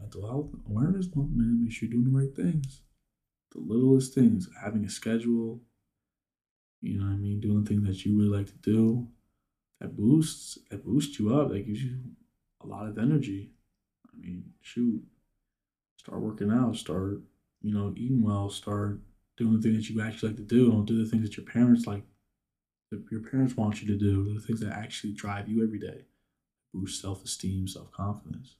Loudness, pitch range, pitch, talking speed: -29 LUFS, 100-120 Hz, 110 Hz, 195 wpm